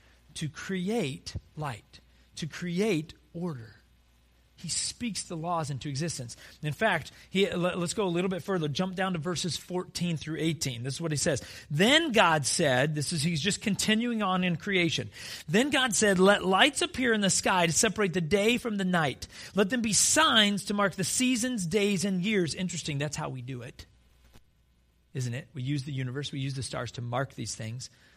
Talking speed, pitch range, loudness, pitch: 195 wpm, 135-200 Hz, -28 LUFS, 170 Hz